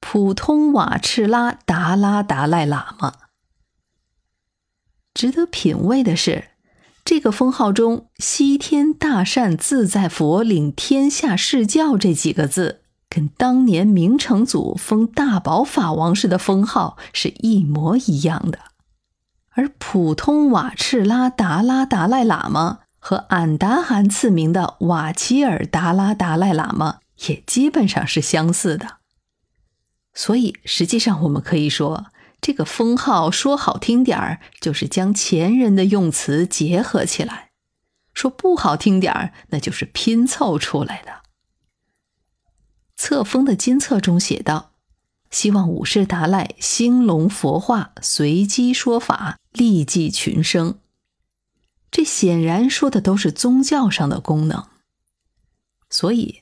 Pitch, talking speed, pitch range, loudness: 200 Hz, 190 characters per minute, 165-250 Hz, -18 LUFS